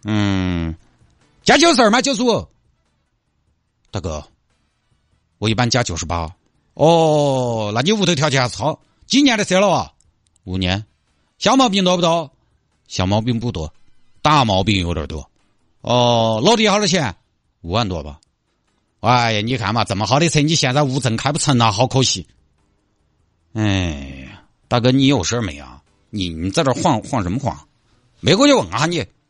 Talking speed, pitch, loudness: 230 characters per minute, 110 Hz, -17 LUFS